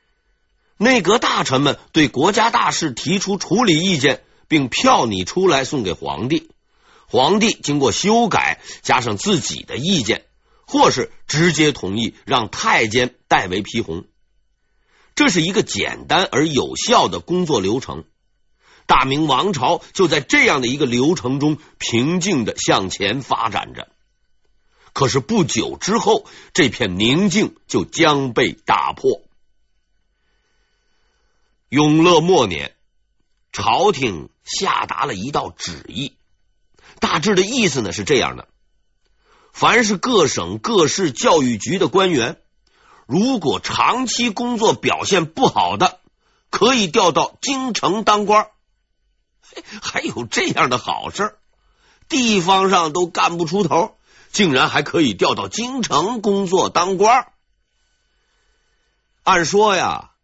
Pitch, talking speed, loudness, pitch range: 185 Hz, 185 characters per minute, -17 LUFS, 150-220 Hz